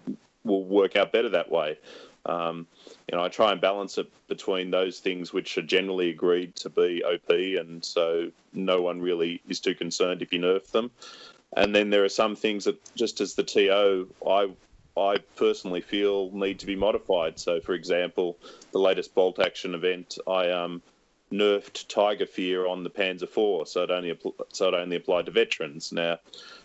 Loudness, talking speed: -27 LUFS, 185 wpm